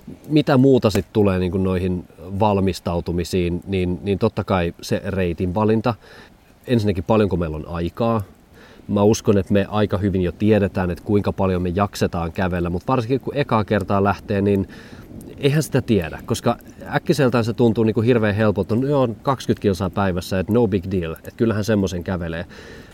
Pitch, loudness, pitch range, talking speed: 100 Hz, -20 LUFS, 95-115 Hz, 170 wpm